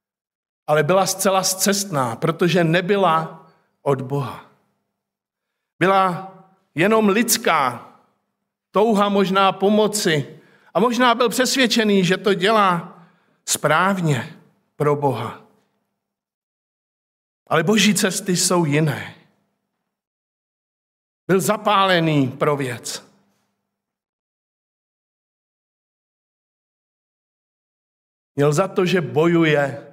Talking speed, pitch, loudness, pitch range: 75 wpm, 185 Hz, -18 LUFS, 150-200 Hz